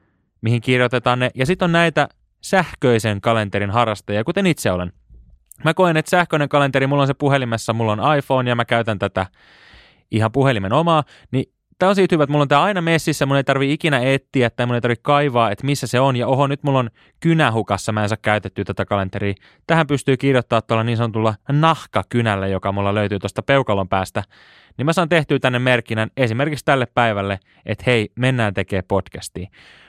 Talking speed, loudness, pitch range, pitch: 195 wpm, -18 LUFS, 105-145 Hz, 125 Hz